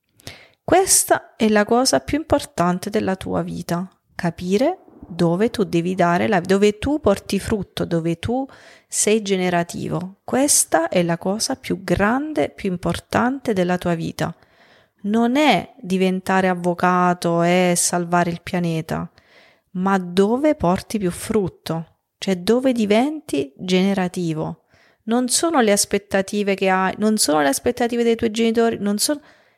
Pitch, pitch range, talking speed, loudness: 195 Hz, 175-230 Hz, 135 wpm, -20 LUFS